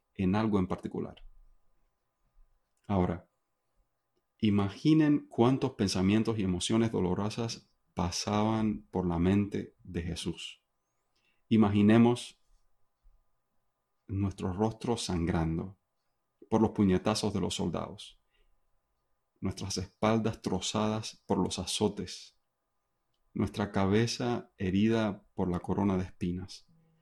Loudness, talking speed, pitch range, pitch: -31 LUFS, 90 wpm, 95-110 Hz, 105 Hz